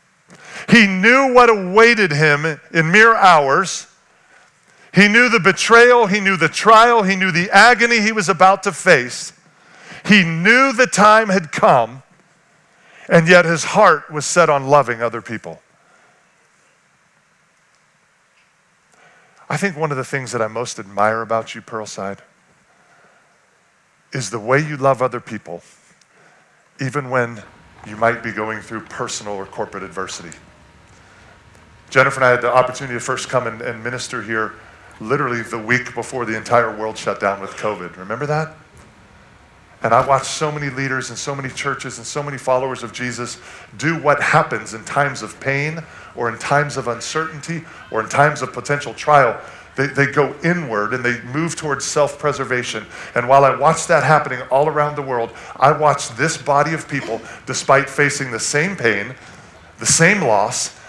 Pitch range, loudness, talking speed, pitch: 115-160 Hz, -16 LUFS, 165 wpm, 135 Hz